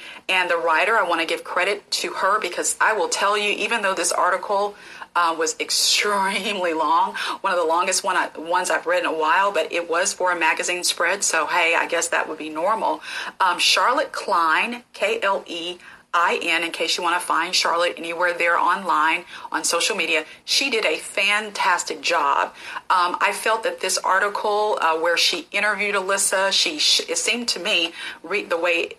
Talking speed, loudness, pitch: 190 wpm, -20 LUFS, 205 Hz